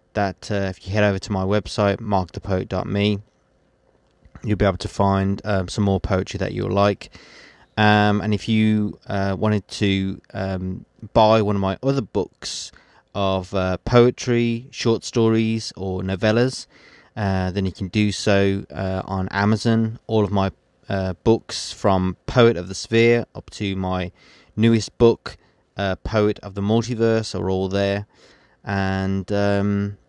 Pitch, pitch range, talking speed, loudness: 100 Hz, 95-110 Hz, 155 wpm, -21 LUFS